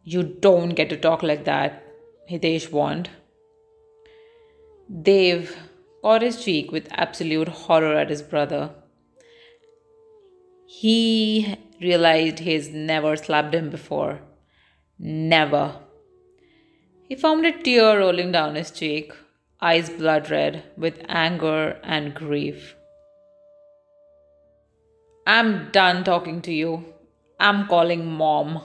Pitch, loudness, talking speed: 175 Hz, -21 LUFS, 105 wpm